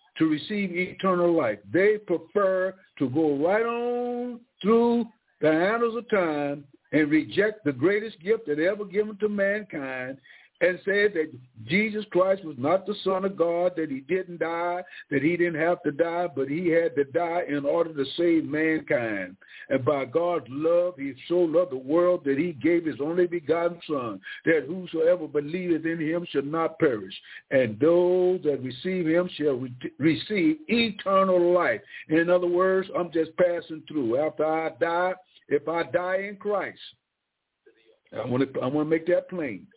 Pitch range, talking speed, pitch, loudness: 155-195 Hz, 165 wpm, 175 Hz, -25 LUFS